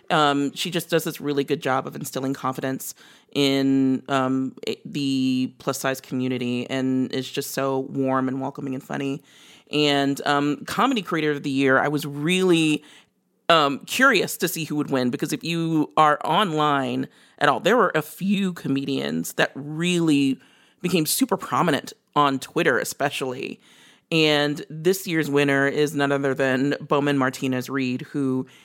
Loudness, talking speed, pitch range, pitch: -23 LUFS, 155 wpm, 135-155 Hz, 140 Hz